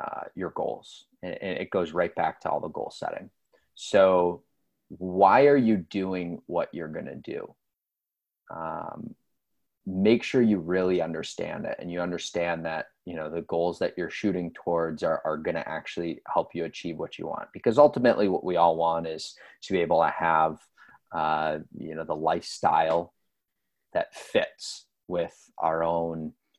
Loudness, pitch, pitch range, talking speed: -27 LUFS, 85 Hz, 80-95 Hz, 170 wpm